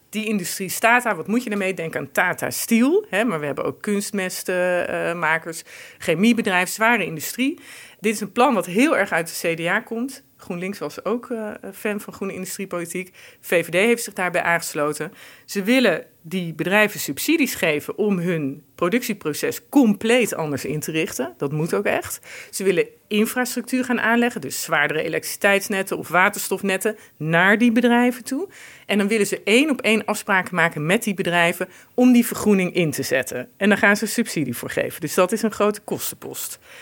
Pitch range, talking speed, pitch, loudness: 175-230 Hz, 175 wpm, 205 Hz, -21 LUFS